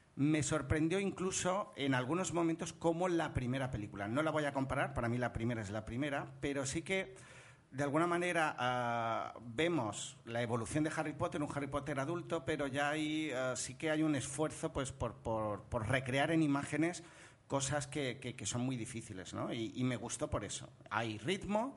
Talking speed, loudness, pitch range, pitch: 195 wpm, -37 LUFS, 120-160 Hz, 140 Hz